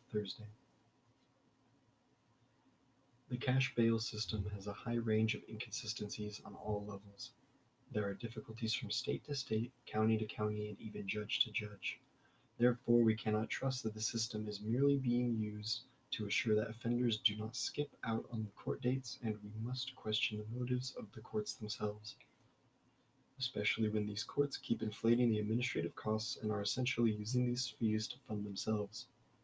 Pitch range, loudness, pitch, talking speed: 105-125 Hz, -38 LUFS, 115 Hz, 165 wpm